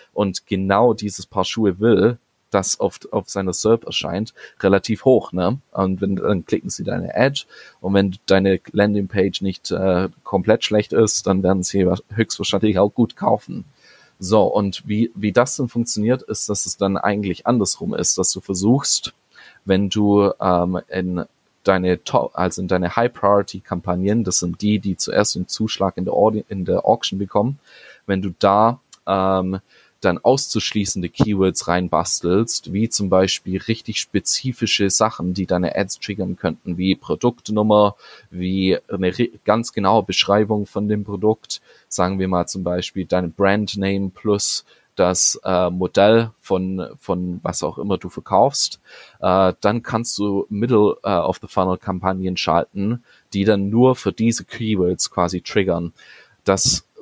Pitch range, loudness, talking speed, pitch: 95-110 Hz, -19 LUFS, 150 wpm, 100 Hz